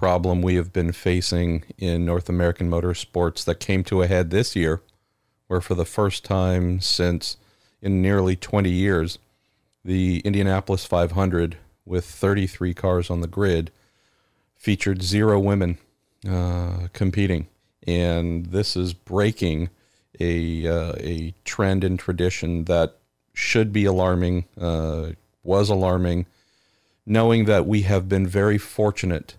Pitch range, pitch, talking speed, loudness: 85-100 Hz, 90 Hz, 135 wpm, -23 LUFS